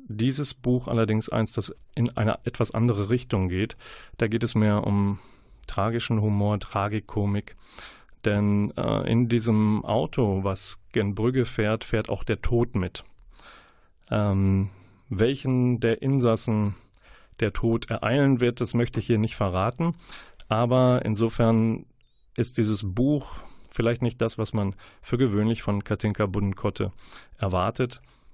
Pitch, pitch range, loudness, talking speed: 110 Hz, 105-120 Hz, -26 LUFS, 130 wpm